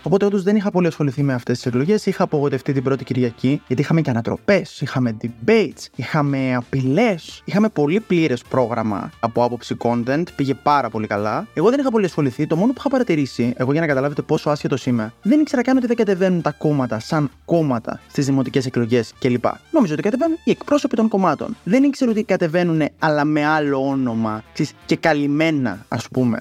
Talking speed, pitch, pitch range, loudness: 190 wpm, 145 Hz, 125-185 Hz, -19 LUFS